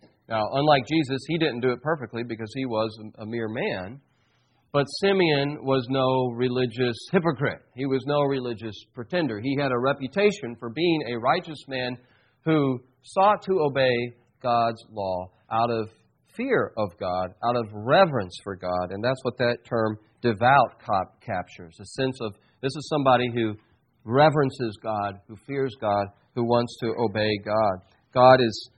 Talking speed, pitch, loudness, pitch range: 160 wpm, 120 Hz, -25 LUFS, 110-135 Hz